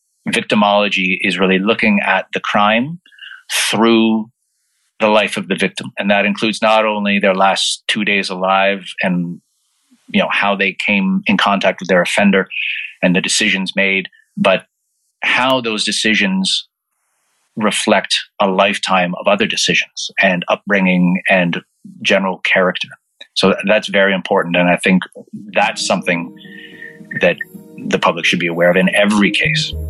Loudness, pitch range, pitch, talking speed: -14 LUFS, 95-110 Hz, 100 Hz, 145 wpm